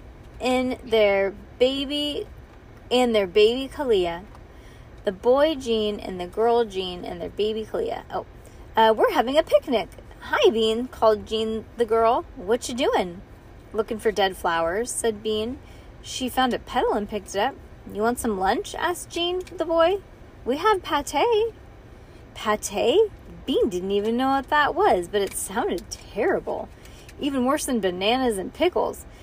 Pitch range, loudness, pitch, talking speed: 215-295 Hz, -24 LUFS, 235 Hz, 155 wpm